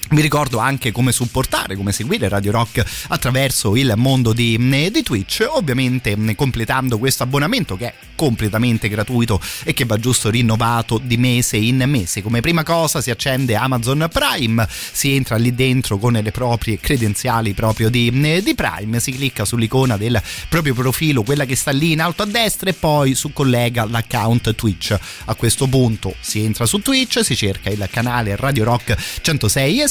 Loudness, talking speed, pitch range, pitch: -17 LUFS, 175 wpm, 110-135 Hz, 120 Hz